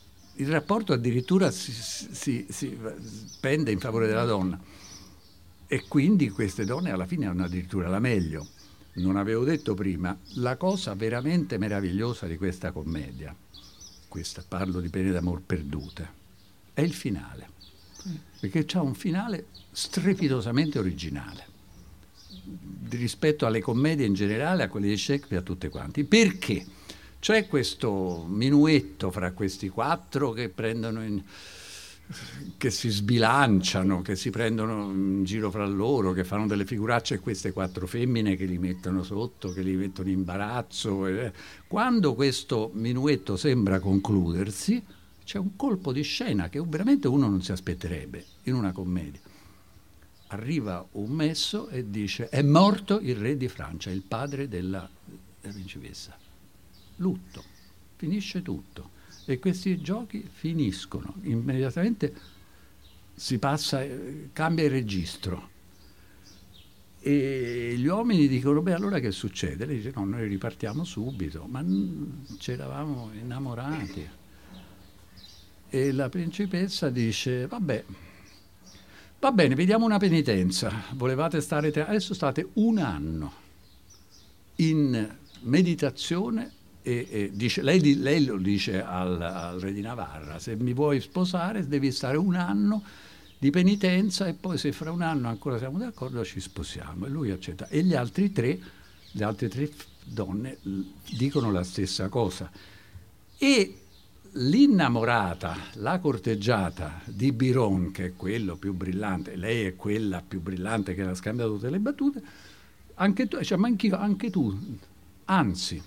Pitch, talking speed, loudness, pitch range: 105 Hz, 135 wpm, -28 LUFS, 95-145 Hz